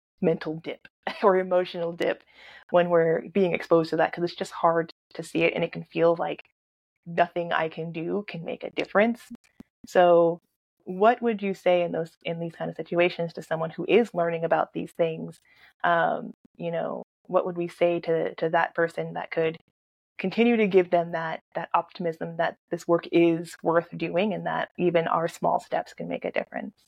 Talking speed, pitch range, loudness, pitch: 195 wpm, 165-180 Hz, -26 LUFS, 170 Hz